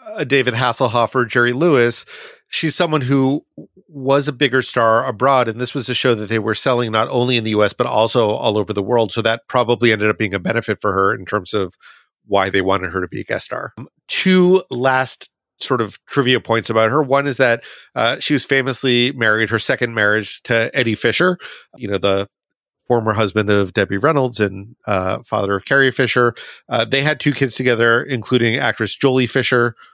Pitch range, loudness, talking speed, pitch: 110-135 Hz, -17 LUFS, 205 wpm, 120 Hz